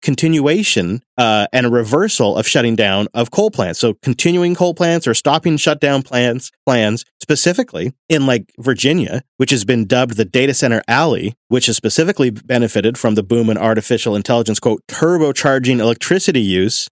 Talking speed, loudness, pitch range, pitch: 165 wpm, -15 LUFS, 115-150 Hz, 130 Hz